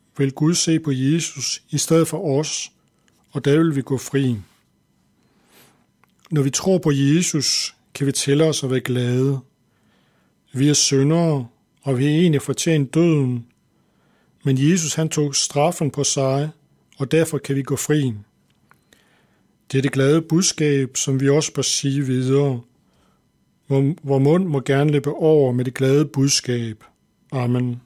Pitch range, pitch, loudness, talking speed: 135-150 Hz, 140 Hz, -19 LUFS, 155 wpm